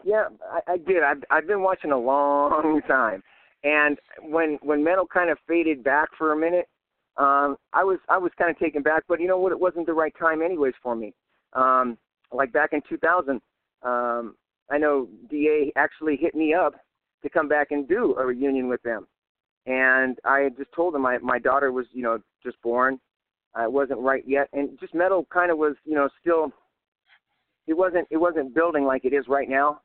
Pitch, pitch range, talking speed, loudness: 145 Hz, 135-165 Hz, 205 wpm, -23 LUFS